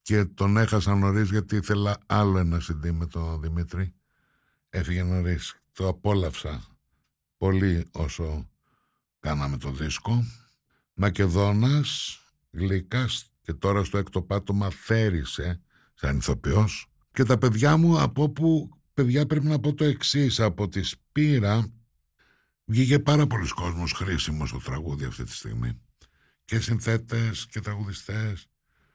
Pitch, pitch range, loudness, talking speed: 100 Hz, 85-115 Hz, -26 LUFS, 125 wpm